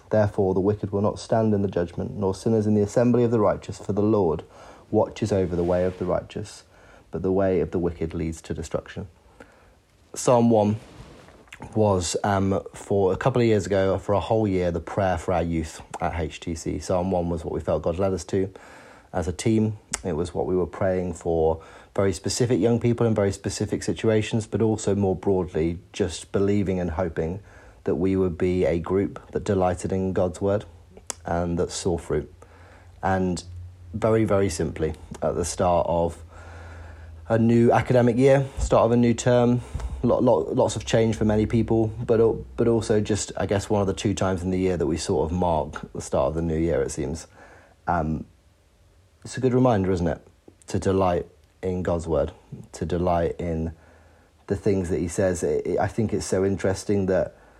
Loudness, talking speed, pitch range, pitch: -24 LUFS, 190 wpm, 85-105 Hz, 95 Hz